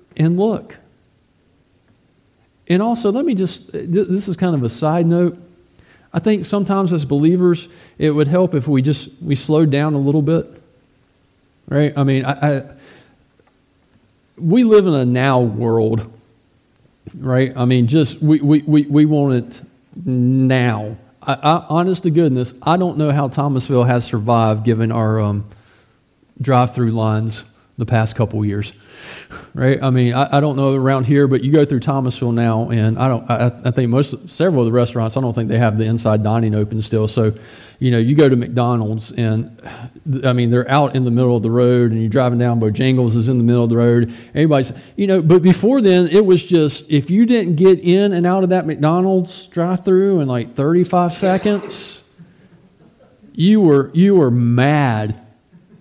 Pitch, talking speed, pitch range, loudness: 135 Hz, 185 wpm, 120-170 Hz, -16 LUFS